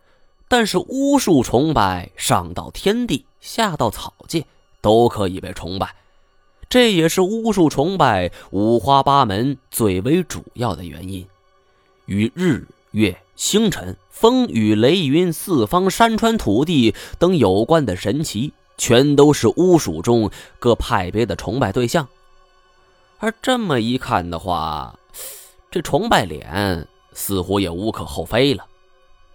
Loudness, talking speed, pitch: -18 LUFS, 190 characters per minute, 120 Hz